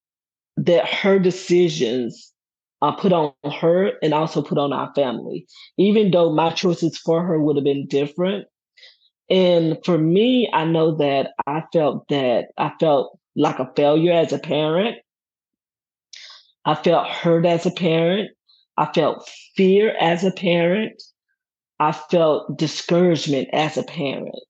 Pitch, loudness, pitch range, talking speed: 170 Hz, -19 LUFS, 155-185 Hz, 145 wpm